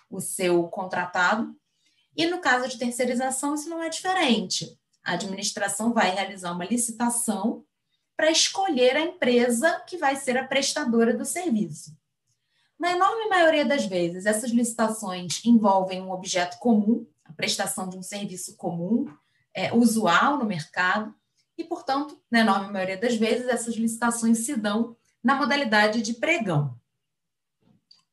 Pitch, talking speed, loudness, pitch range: 230 Hz, 140 wpm, -24 LUFS, 190-270 Hz